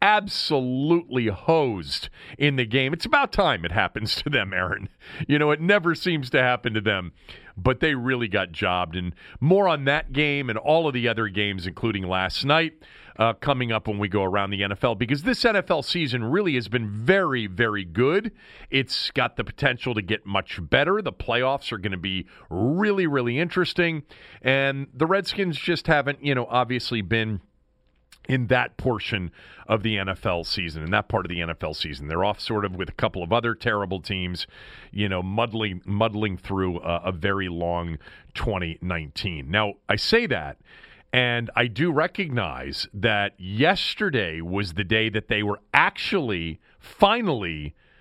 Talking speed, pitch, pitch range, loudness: 175 wpm, 115 Hz, 95-140 Hz, -24 LUFS